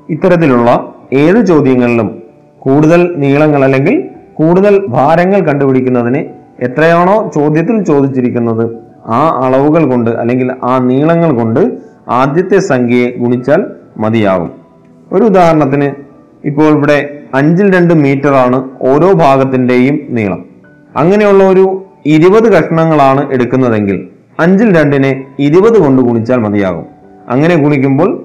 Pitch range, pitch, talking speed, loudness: 125-160 Hz, 140 Hz, 100 wpm, -9 LUFS